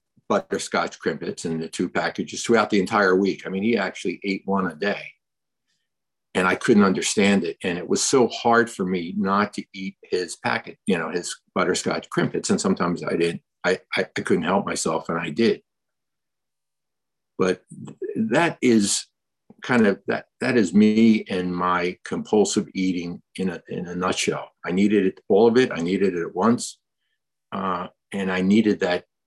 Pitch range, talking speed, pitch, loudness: 90-105 Hz, 180 wpm, 95 Hz, -22 LUFS